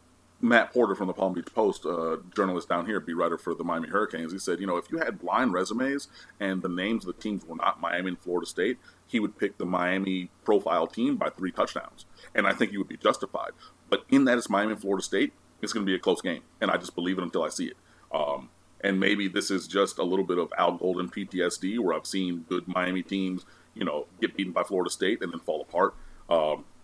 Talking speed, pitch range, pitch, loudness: 250 wpm, 90-100 Hz, 90 Hz, -28 LUFS